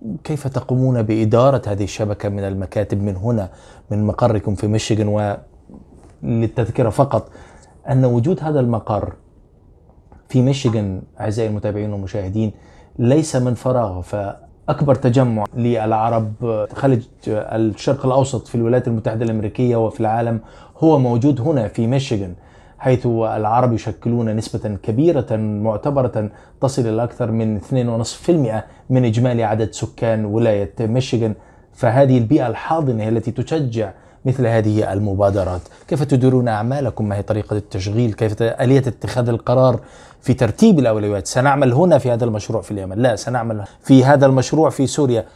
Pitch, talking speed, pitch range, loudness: 115 Hz, 130 wpm, 105-130 Hz, -18 LUFS